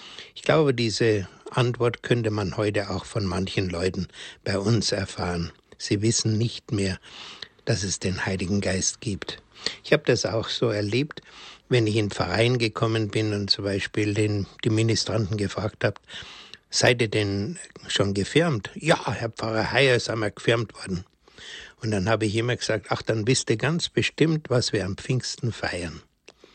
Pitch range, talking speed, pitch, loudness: 100-120 Hz, 165 wpm, 110 Hz, -25 LUFS